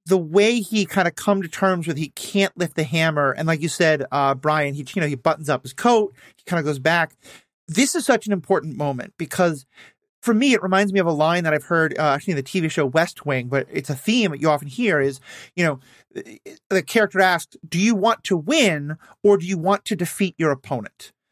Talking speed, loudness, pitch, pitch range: 245 wpm, -21 LUFS, 170 Hz, 150-200 Hz